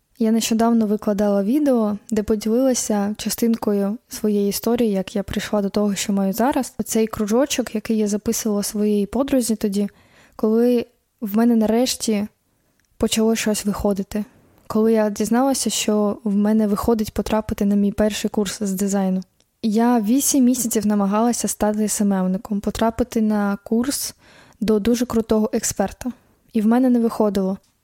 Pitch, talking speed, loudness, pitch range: 220 Hz, 140 wpm, -20 LUFS, 205-230 Hz